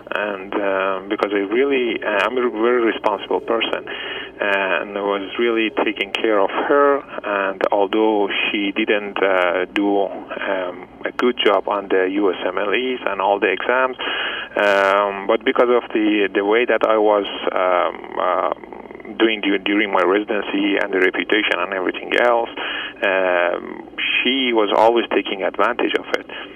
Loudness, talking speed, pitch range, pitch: -19 LUFS, 145 wpm, 100-125 Hz, 110 Hz